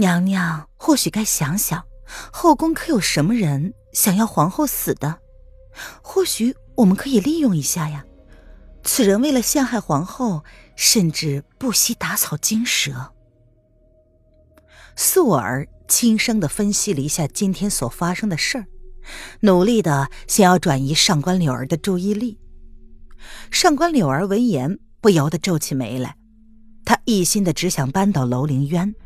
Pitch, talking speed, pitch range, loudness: 180 Hz, 215 characters per minute, 140-220 Hz, -19 LUFS